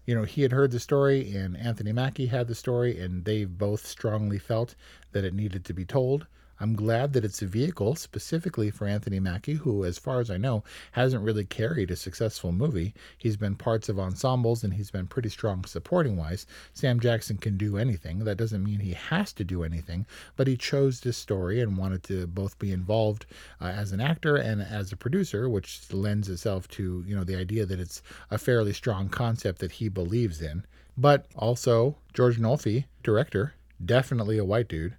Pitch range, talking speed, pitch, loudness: 95-125 Hz, 200 wpm, 110 Hz, -28 LUFS